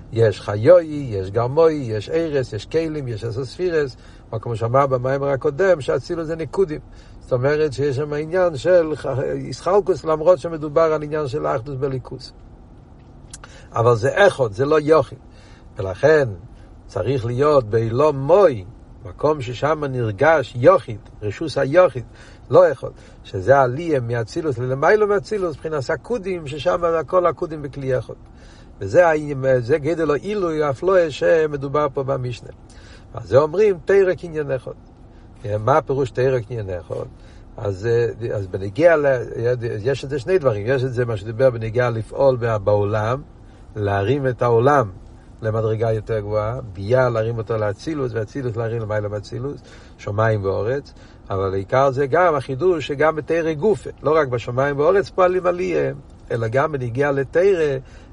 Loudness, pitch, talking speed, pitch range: -20 LUFS, 135 Hz, 135 wpm, 115-155 Hz